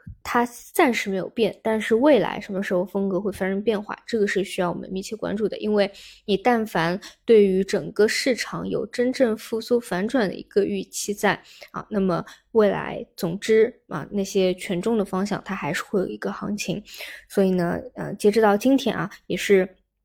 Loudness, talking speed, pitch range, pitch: -23 LUFS, 280 characters per minute, 190-220 Hz, 200 Hz